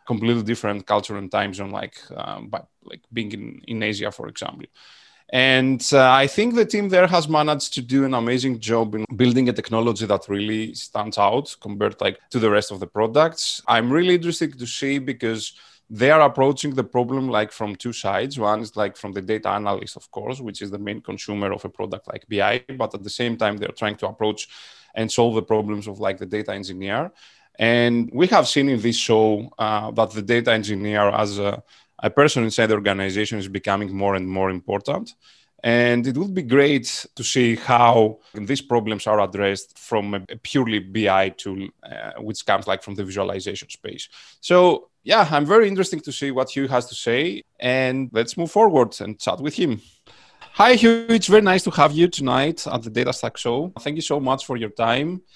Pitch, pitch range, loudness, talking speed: 115 Hz, 105-135 Hz, -20 LUFS, 205 wpm